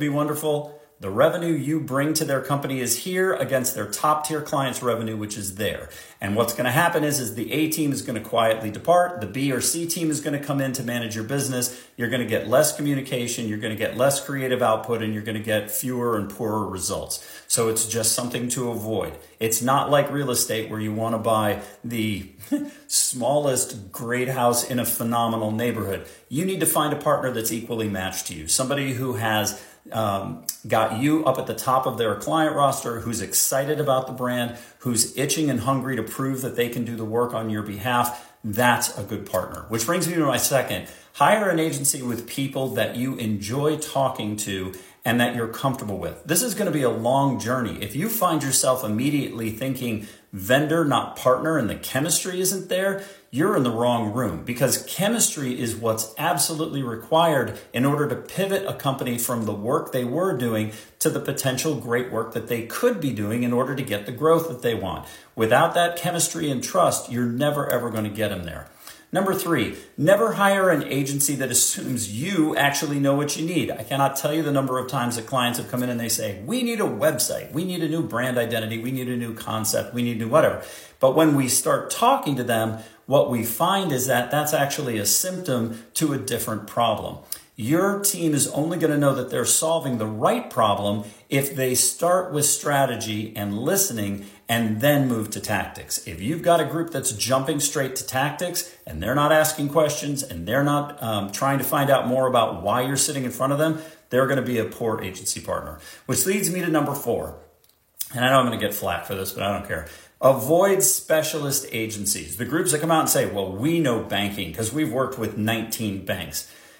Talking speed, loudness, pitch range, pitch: 215 wpm, -23 LUFS, 110-150 Hz, 125 Hz